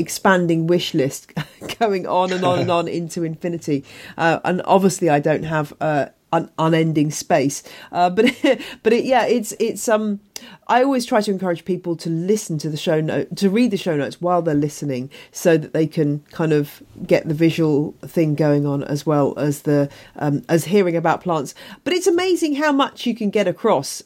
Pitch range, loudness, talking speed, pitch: 150-205 Hz, -19 LUFS, 200 wpm, 170 Hz